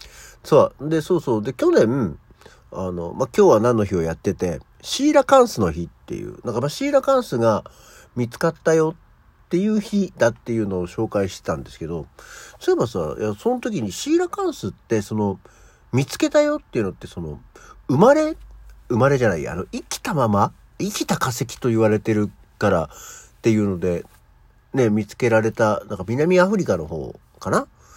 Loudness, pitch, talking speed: -21 LUFS, 120 Hz, 355 characters per minute